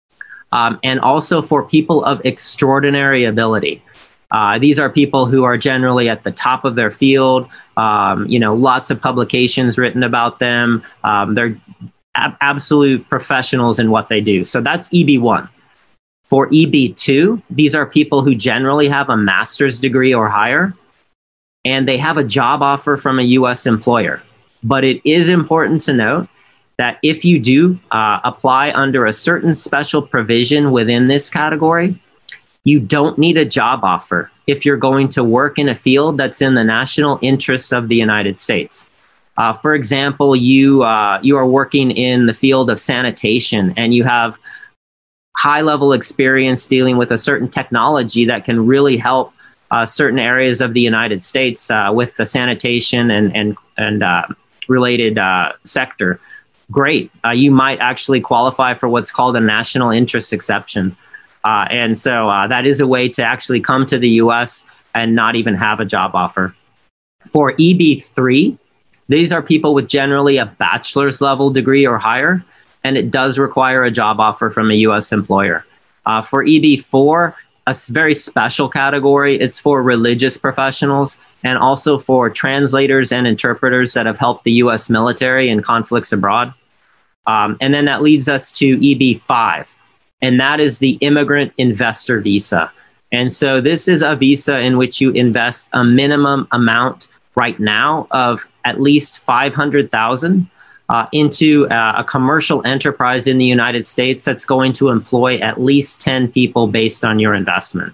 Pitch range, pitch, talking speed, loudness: 115-140 Hz, 130 Hz, 165 wpm, -13 LUFS